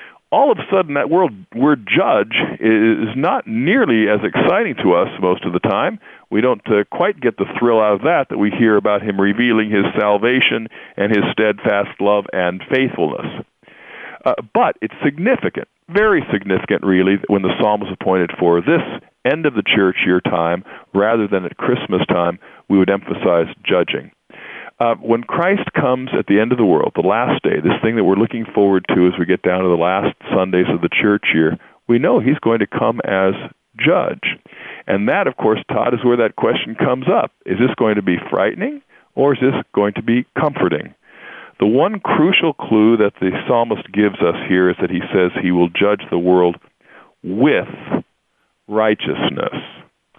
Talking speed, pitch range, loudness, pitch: 190 wpm, 95-115 Hz, -16 LUFS, 105 Hz